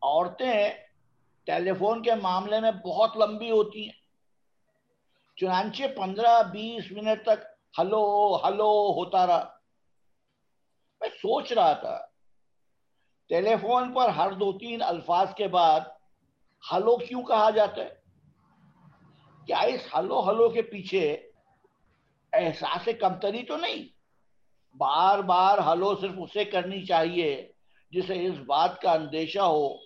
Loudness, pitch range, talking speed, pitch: -26 LUFS, 185-230 Hz, 120 wpm, 210 Hz